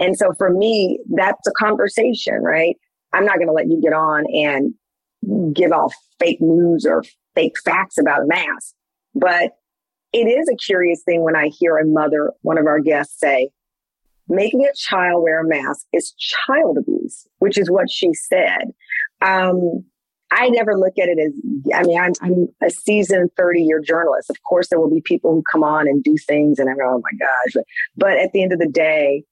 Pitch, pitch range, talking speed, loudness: 175 Hz, 155-200 Hz, 205 wpm, -17 LUFS